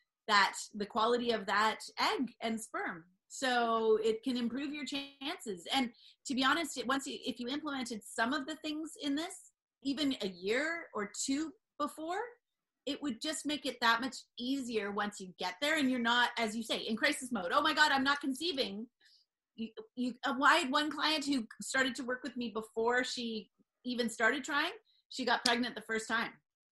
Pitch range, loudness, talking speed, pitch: 225-290 Hz, -34 LUFS, 190 wpm, 255 Hz